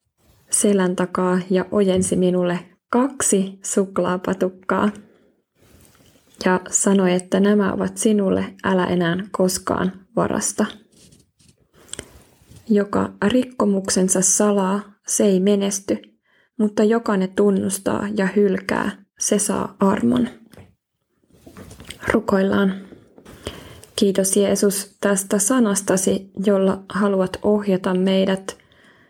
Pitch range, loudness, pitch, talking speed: 185-205 Hz, -20 LUFS, 195 Hz, 85 wpm